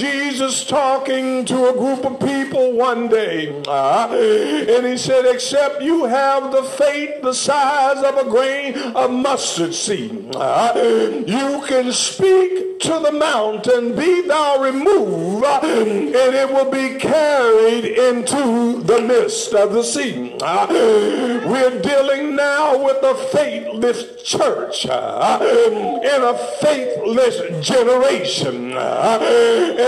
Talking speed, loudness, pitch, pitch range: 125 wpm, -16 LUFS, 270 Hz, 245-290 Hz